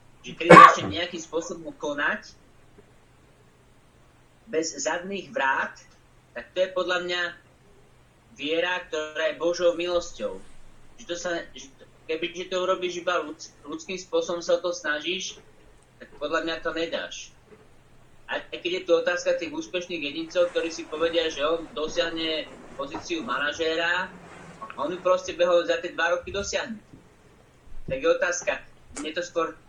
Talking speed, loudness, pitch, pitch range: 140 wpm, -25 LUFS, 175 Hz, 160-180 Hz